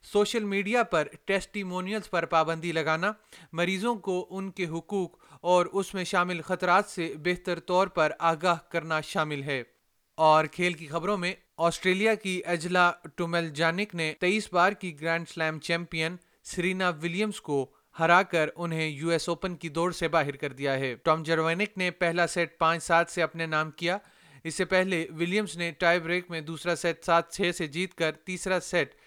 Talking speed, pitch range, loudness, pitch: 180 wpm, 165-185 Hz, -28 LUFS, 175 Hz